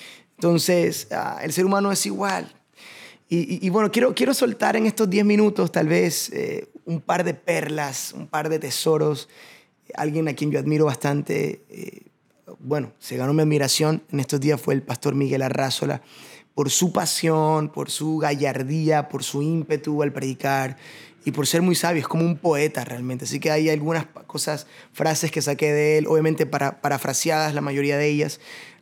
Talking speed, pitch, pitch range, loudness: 180 wpm, 155 Hz, 145-165 Hz, -22 LUFS